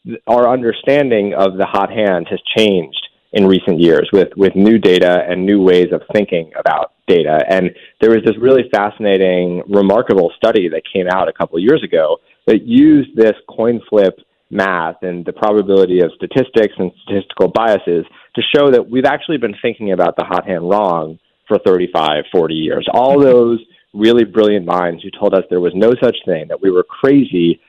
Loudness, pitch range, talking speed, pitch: -13 LUFS, 90-115 Hz, 185 wpm, 100 Hz